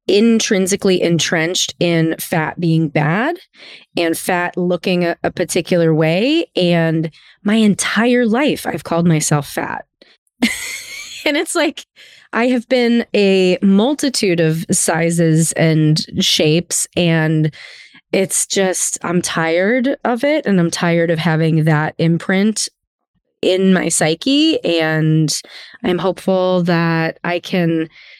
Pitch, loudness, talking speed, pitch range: 175 Hz, -15 LUFS, 120 wpm, 165-200 Hz